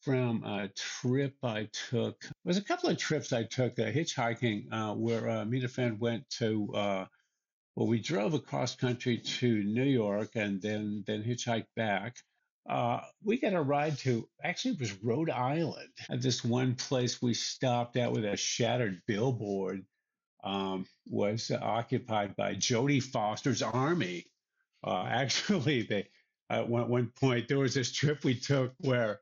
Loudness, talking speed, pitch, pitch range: -32 LUFS, 165 wpm, 120 Hz, 110-135 Hz